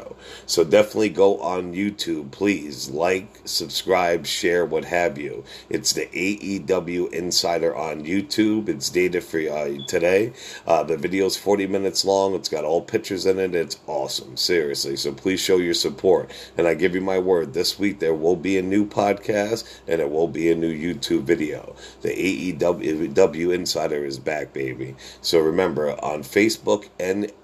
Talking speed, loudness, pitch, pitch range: 170 wpm, -22 LUFS, 95 Hz, 85-100 Hz